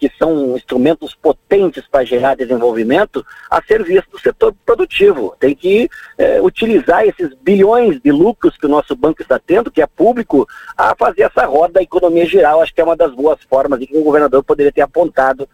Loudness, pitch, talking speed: -13 LUFS, 170 Hz, 195 wpm